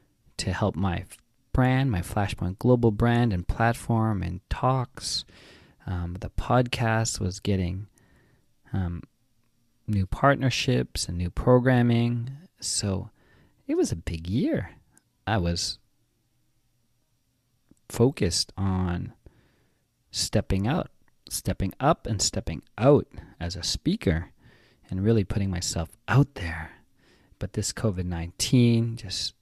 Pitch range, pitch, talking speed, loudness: 90-120 Hz, 105 Hz, 110 wpm, -26 LUFS